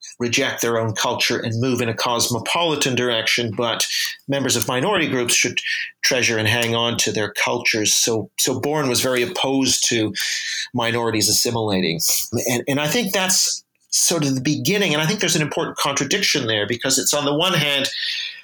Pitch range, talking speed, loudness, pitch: 115-150 Hz, 180 wpm, -19 LUFS, 125 Hz